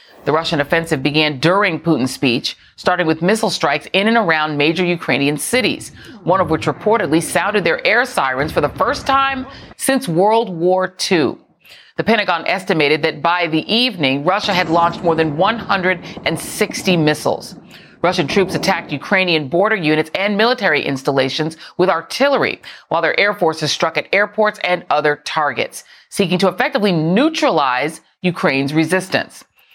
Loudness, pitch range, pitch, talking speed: -16 LUFS, 155-205 Hz, 175 Hz, 150 wpm